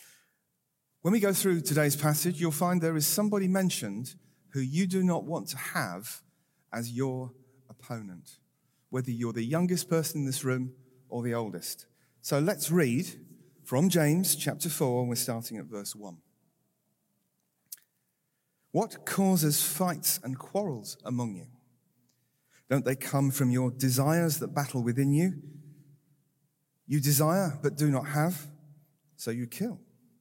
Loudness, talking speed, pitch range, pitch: -29 LUFS, 145 wpm, 125-165 Hz, 145 Hz